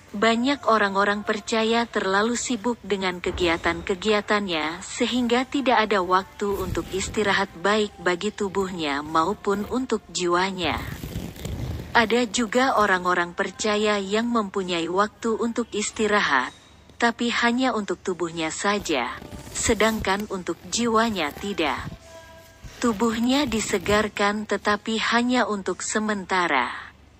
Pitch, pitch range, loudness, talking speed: 205 Hz, 185-225 Hz, -23 LUFS, 95 wpm